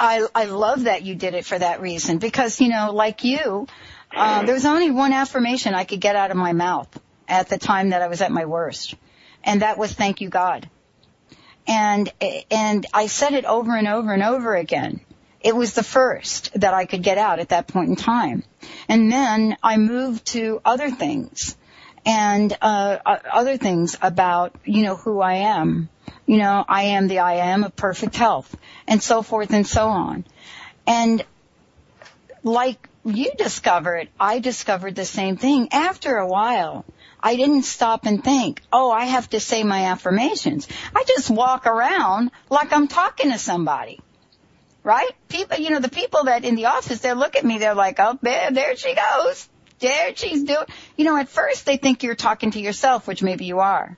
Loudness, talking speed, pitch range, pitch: -20 LUFS, 190 wpm, 195-255 Hz, 225 Hz